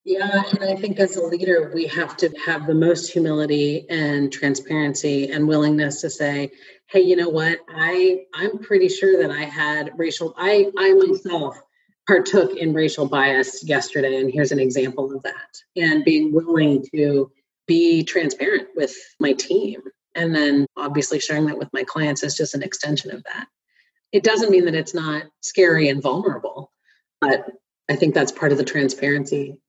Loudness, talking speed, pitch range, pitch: -20 LUFS, 175 wpm, 145-190 Hz, 160 Hz